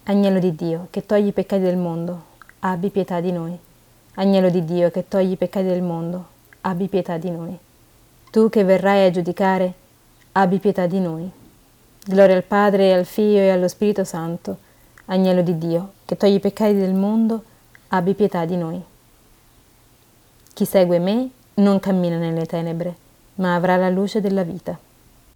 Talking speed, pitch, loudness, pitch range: 165 wpm, 185 Hz, -19 LUFS, 170-195 Hz